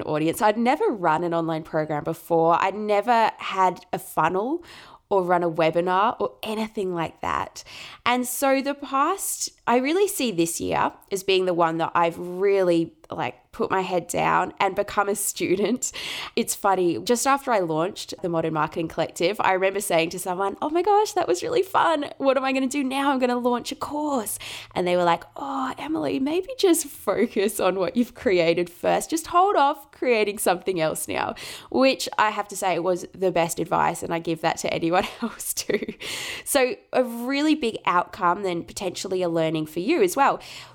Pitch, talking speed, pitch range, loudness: 200 Hz, 195 wpm, 170-275 Hz, -24 LUFS